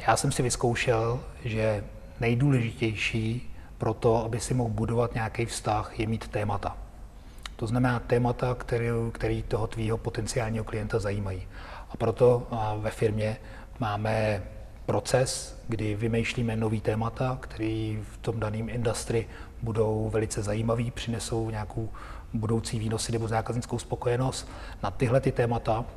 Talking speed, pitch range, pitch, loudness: 130 wpm, 110-120 Hz, 115 Hz, -29 LUFS